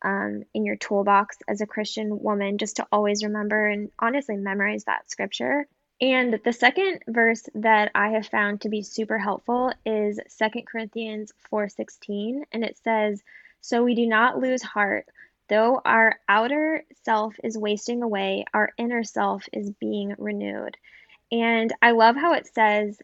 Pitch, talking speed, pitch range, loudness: 215 Hz, 160 wpm, 205-235 Hz, -24 LUFS